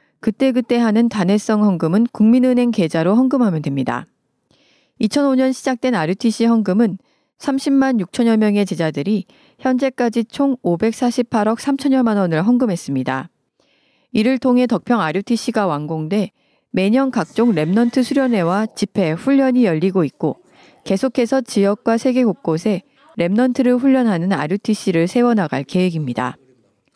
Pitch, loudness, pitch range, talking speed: 225 Hz, -17 LUFS, 185-255 Hz, 300 characters per minute